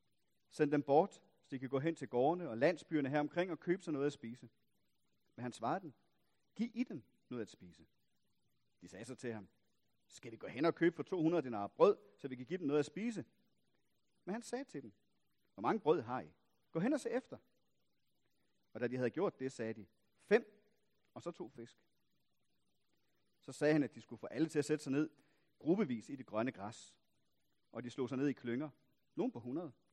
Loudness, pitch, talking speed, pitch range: -39 LUFS, 145 Hz, 220 wpm, 120-170 Hz